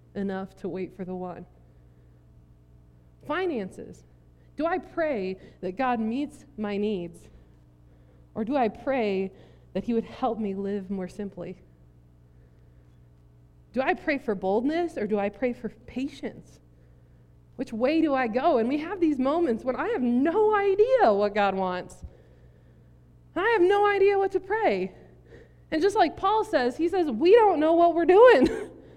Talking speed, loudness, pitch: 155 wpm, -25 LUFS, 205 Hz